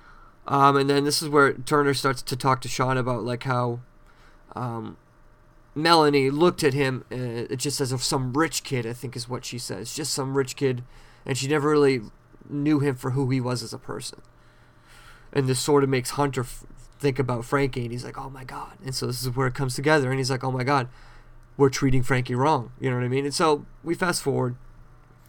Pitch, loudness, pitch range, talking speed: 130 Hz, -24 LUFS, 125-140 Hz, 225 wpm